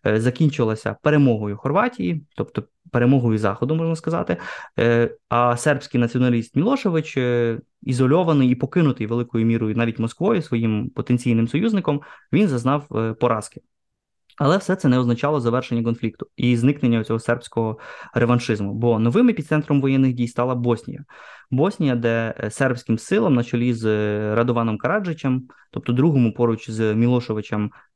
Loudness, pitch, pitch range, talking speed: -21 LUFS, 120 Hz, 115-140 Hz, 125 wpm